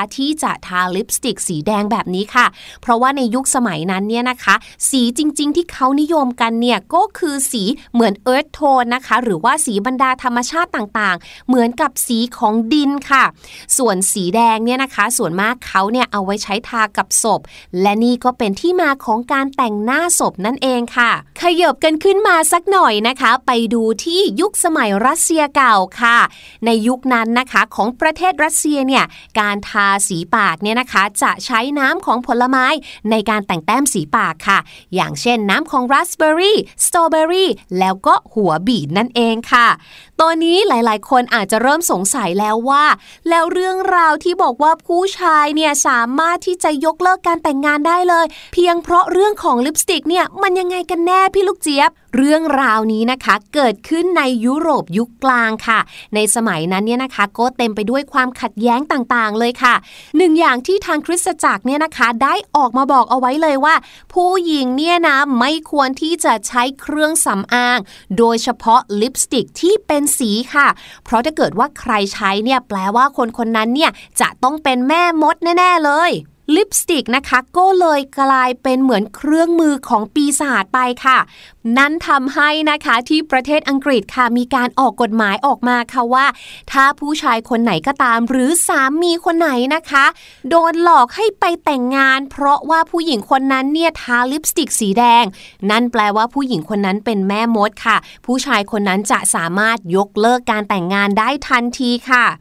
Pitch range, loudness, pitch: 230-310 Hz, -14 LUFS, 255 Hz